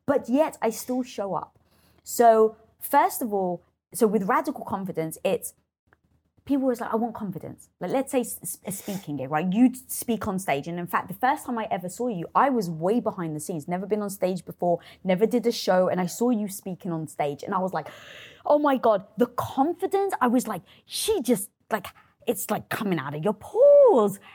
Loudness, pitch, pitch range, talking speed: -25 LUFS, 215 Hz, 185-250 Hz, 210 wpm